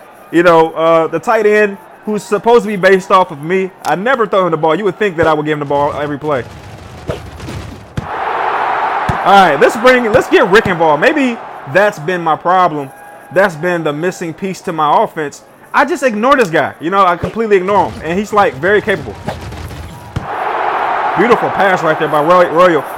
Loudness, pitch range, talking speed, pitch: -12 LUFS, 160-215 Hz, 195 wpm, 185 Hz